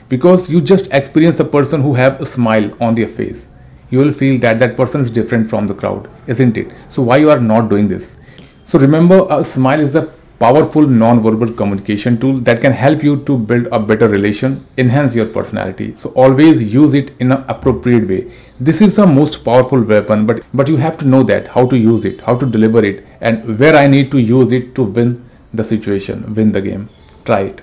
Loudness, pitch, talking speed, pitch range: -12 LUFS, 125 Hz, 215 wpm, 115-145 Hz